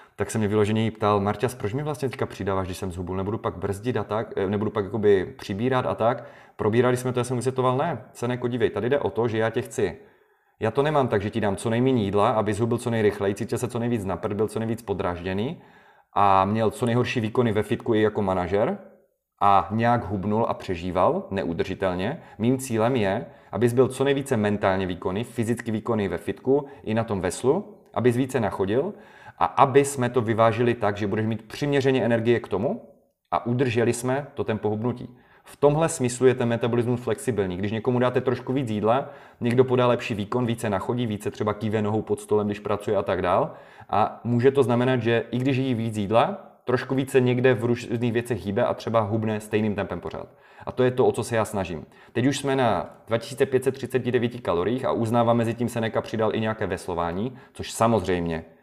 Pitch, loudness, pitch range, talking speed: 115 Hz, -24 LUFS, 105-125 Hz, 205 wpm